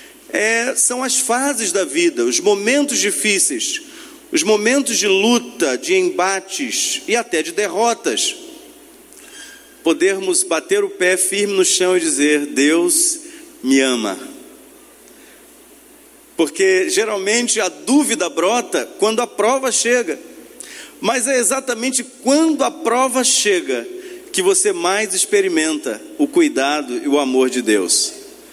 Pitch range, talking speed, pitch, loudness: 220-355 Hz, 120 wpm, 285 Hz, -16 LUFS